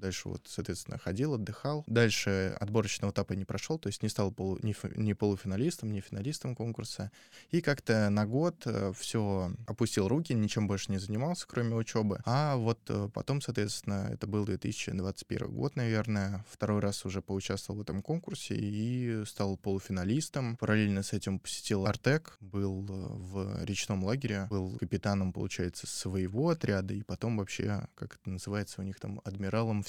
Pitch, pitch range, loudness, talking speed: 105 Hz, 100-115 Hz, -34 LUFS, 155 wpm